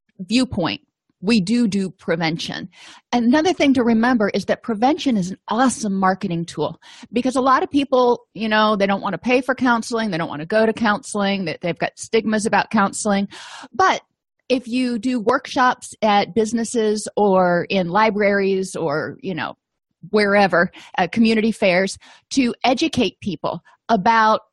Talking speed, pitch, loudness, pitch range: 160 wpm, 220 Hz, -19 LUFS, 195-245 Hz